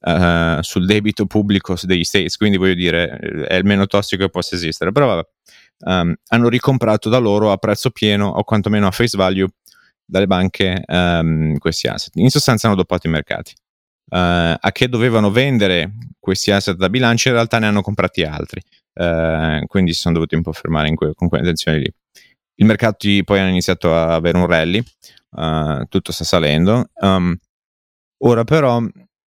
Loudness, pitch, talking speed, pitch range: -16 LUFS, 95 Hz, 180 wpm, 85-105 Hz